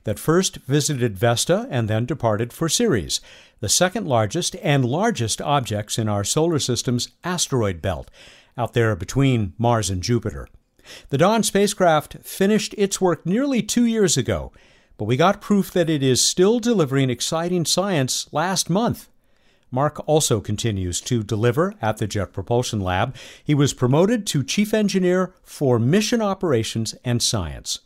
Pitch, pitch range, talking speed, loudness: 135 Hz, 115-180 Hz, 155 wpm, -21 LUFS